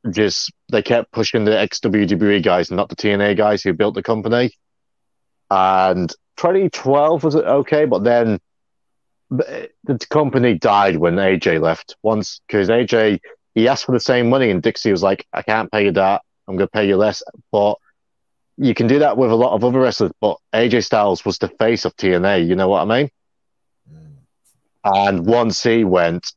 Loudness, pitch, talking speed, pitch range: -17 LUFS, 110 Hz, 180 wpm, 95-125 Hz